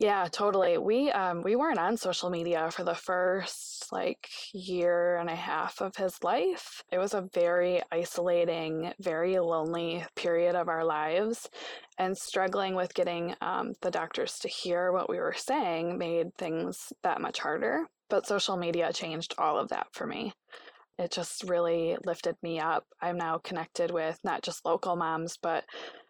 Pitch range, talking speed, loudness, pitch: 170-185 Hz, 170 wpm, -31 LUFS, 175 Hz